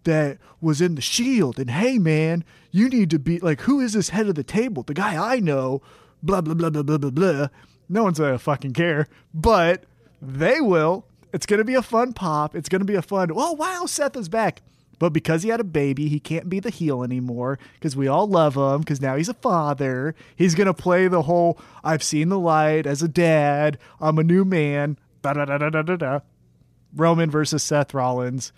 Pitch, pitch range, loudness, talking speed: 160 Hz, 145-190 Hz, -22 LUFS, 200 wpm